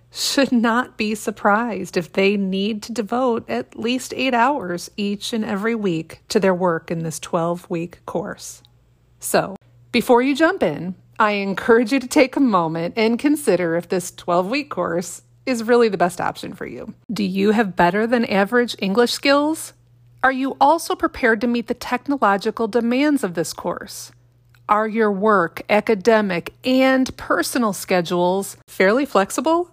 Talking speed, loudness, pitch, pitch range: 160 wpm, -19 LUFS, 215 Hz, 180-245 Hz